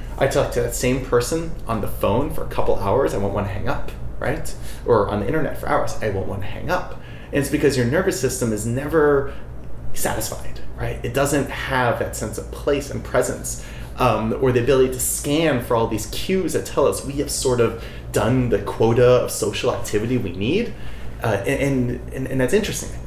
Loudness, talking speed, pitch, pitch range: -21 LUFS, 215 wpm, 125 Hz, 100-140 Hz